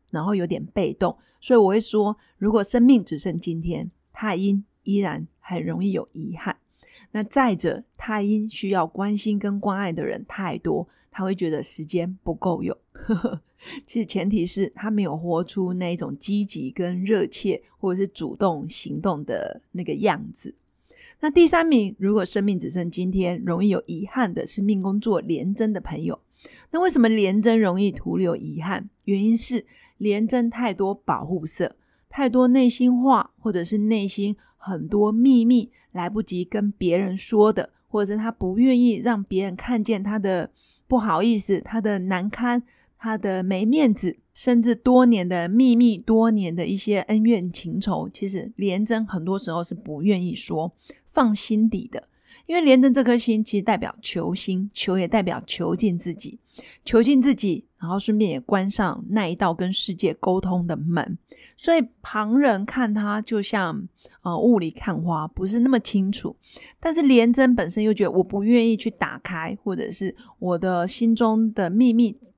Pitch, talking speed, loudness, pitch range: 205 Hz, 250 characters per minute, -22 LUFS, 185-230 Hz